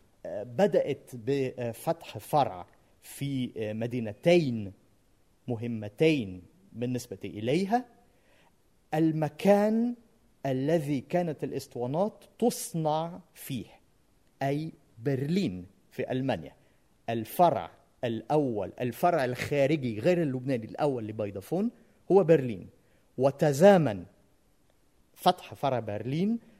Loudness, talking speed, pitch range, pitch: -29 LUFS, 70 wpm, 115-170 Hz, 135 Hz